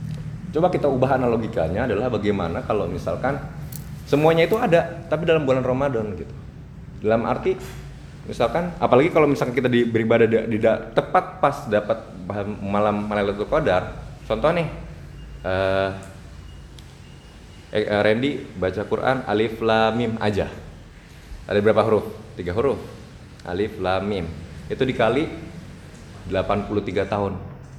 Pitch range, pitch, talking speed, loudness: 100-140 Hz, 110 Hz, 115 wpm, -22 LUFS